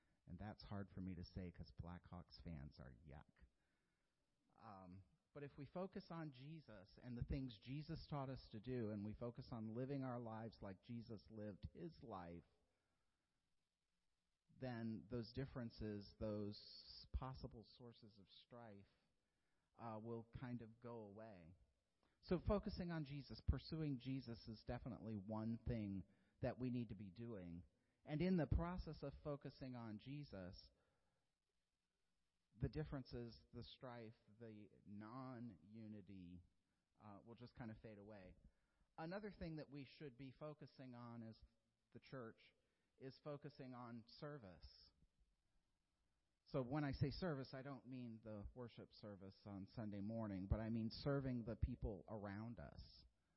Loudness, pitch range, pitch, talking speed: -52 LUFS, 100-130 Hz, 115 Hz, 145 wpm